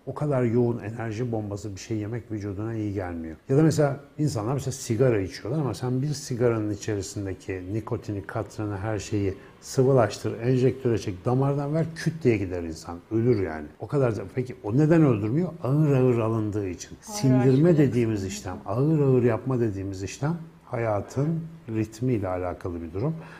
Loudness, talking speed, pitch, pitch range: -26 LUFS, 160 wpm, 115 Hz, 105-135 Hz